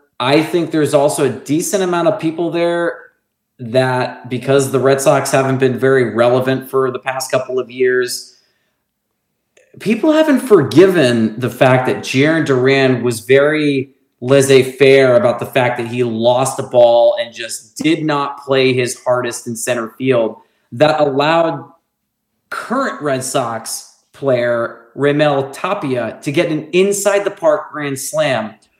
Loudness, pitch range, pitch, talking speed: -14 LUFS, 125-150 Hz, 135 Hz, 150 wpm